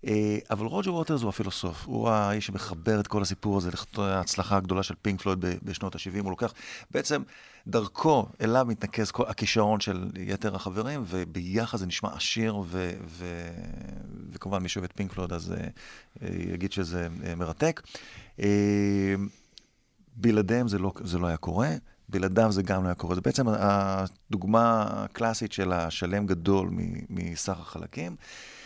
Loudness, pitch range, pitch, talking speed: -29 LUFS, 90-110 Hz, 100 Hz, 150 wpm